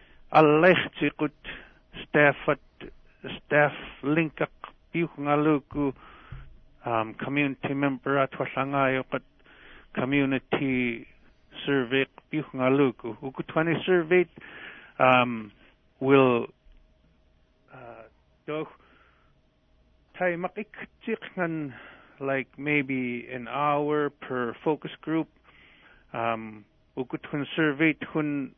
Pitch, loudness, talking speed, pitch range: 140 Hz, -26 LUFS, 90 wpm, 125-150 Hz